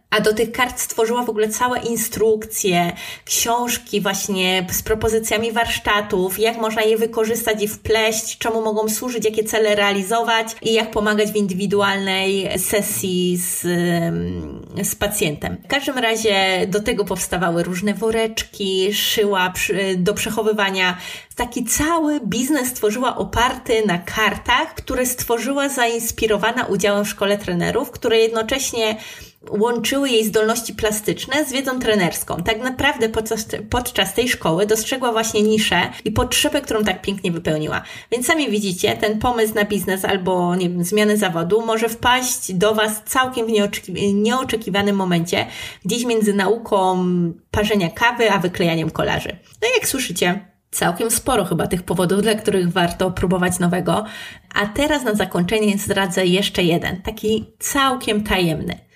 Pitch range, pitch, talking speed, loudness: 195-230 Hz, 215 Hz, 140 wpm, -19 LUFS